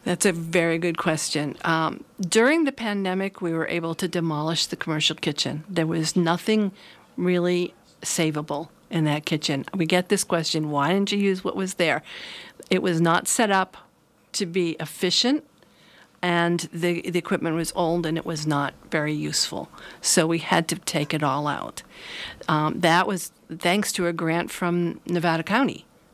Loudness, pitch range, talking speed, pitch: -24 LUFS, 160-185 Hz, 170 wpm, 170 Hz